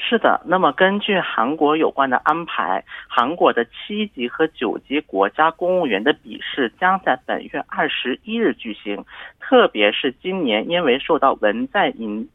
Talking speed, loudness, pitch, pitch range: 250 characters per minute, -19 LUFS, 160 Hz, 125-200 Hz